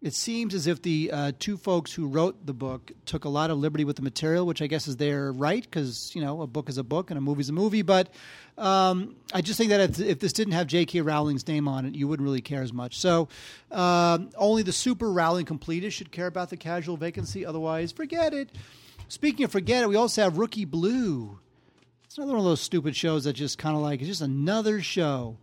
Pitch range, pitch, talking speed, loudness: 145-195 Hz, 170 Hz, 240 wpm, -27 LUFS